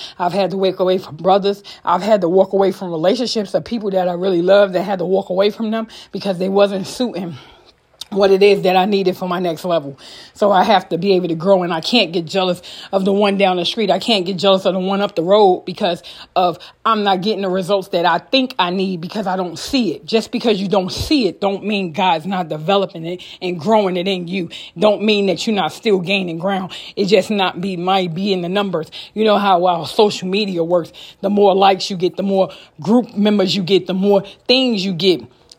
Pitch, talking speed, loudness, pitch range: 190 Hz, 240 wpm, -17 LUFS, 180-200 Hz